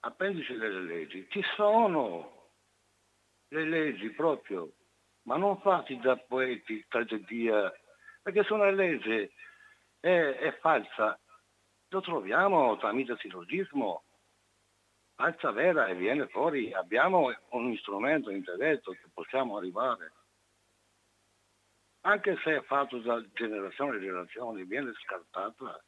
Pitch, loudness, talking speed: 130 Hz, -31 LUFS, 110 wpm